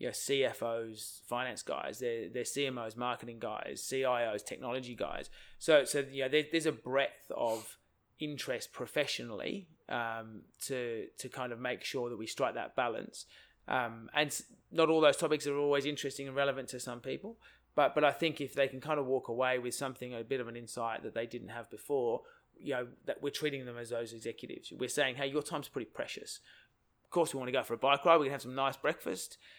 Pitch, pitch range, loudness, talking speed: 135 Hz, 120-145 Hz, -35 LUFS, 210 wpm